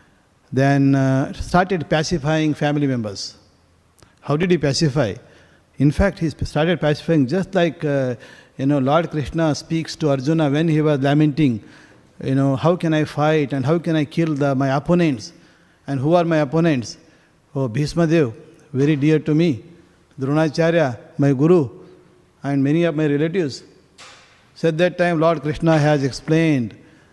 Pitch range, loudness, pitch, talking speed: 135-160 Hz, -19 LUFS, 150 Hz, 155 wpm